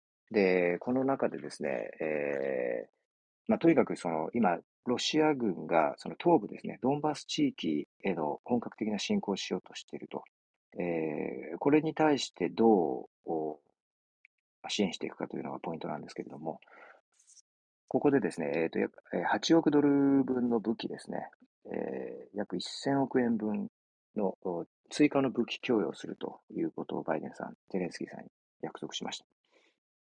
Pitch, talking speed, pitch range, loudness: 135 Hz, 305 characters per minute, 90-155 Hz, -32 LUFS